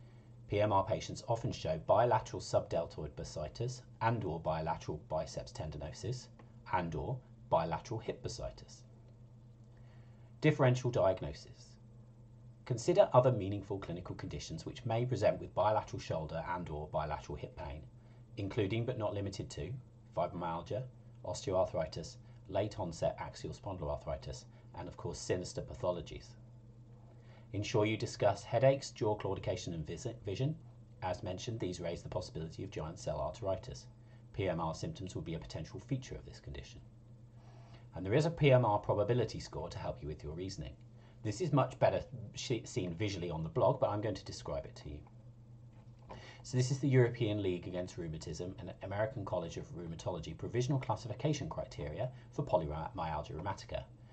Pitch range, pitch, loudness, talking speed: 105-125 Hz, 120 Hz, -37 LUFS, 140 wpm